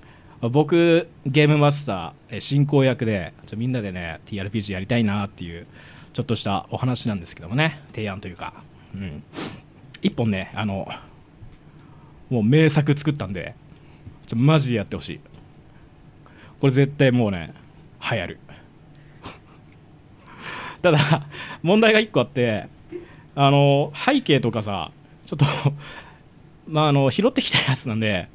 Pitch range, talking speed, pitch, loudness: 105-150 Hz, 265 characters per minute, 130 Hz, -21 LUFS